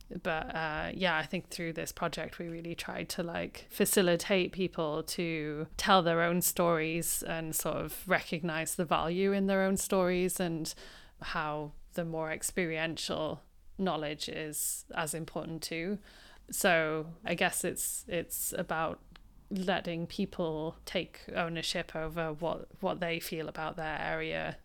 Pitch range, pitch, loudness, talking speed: 160-180 Hz, 165 Hz, -33 LUFS, 140 wpm